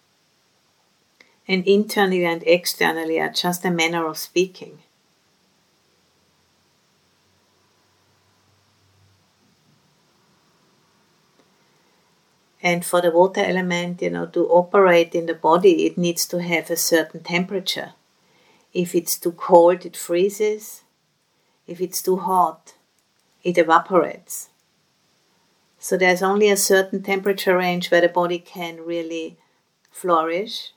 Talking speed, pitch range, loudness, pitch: 105 wpm, 165-185 Hz, -20 LUFS, 175 Hz